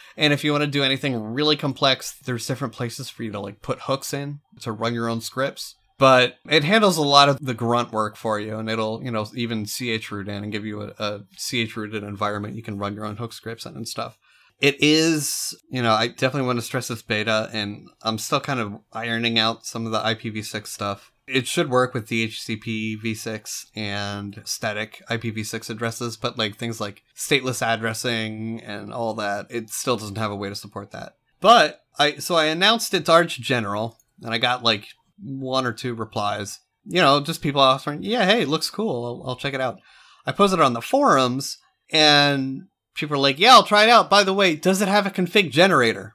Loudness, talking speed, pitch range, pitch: -21 LUFS, 215 wpm, 110-140 Hz, 120 Hz